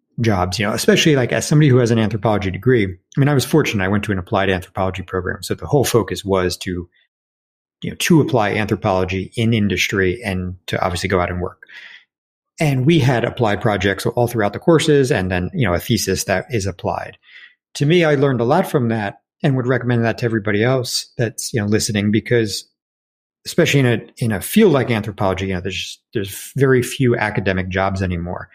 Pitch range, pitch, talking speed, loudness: 95-125 Hz, 110 Hz, 210 wpm, -18 LUFS